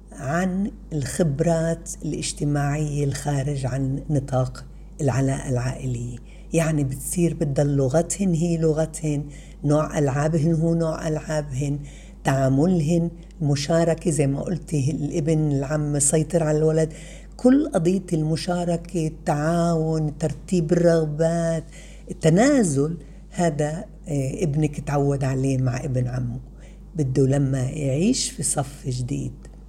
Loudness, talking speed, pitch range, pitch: -23 LUFS, 100 wpm, 140-170 Hz, 155 Hz